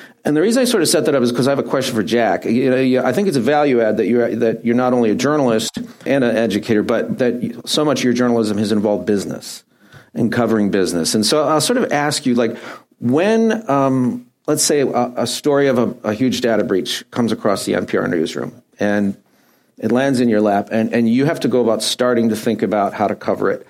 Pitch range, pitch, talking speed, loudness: 110-135 Hz, 120 Hz, 245 wpm, -17 LUFS